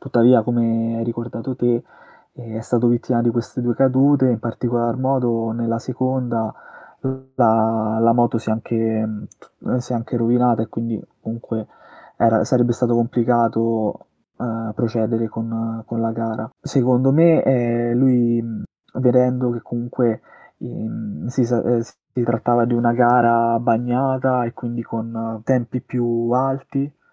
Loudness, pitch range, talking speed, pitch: -20 LUFS, 115-125 Hz, 135 wpm, 120 Hz